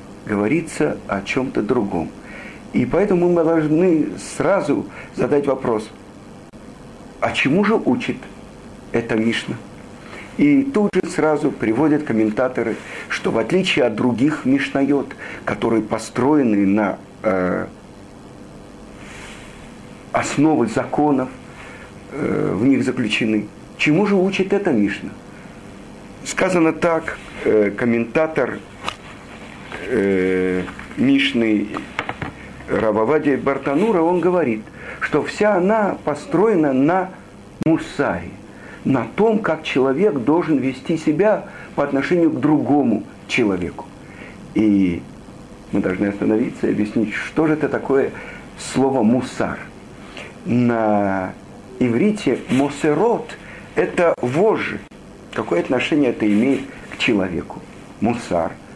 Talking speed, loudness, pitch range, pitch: 95 wpm, -19 LUFS, 105-160 Hz, 135 Hz